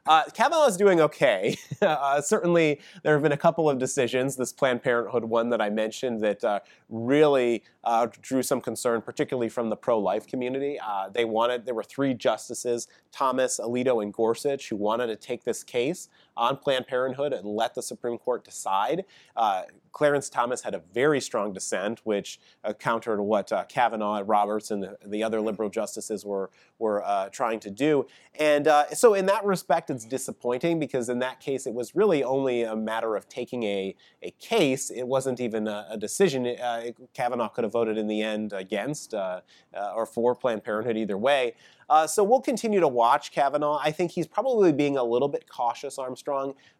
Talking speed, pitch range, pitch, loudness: 190 wpm, 110-145 Hz, 125 Hz, -26 LUFS